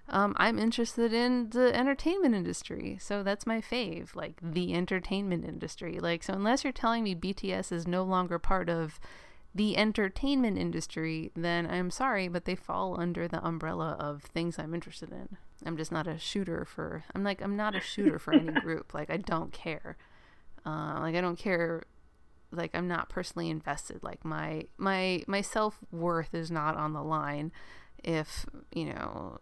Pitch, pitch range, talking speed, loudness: 180 Hz, 165-210 Hz, 175 wpm, -32 LUFS